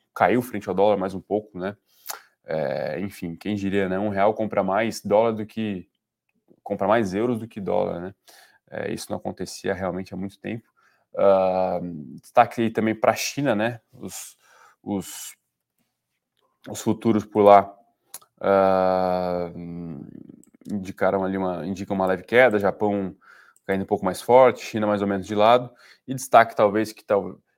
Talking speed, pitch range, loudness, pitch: 160 wpm, 95-110 Hz, -23 LUFS, 100 Hz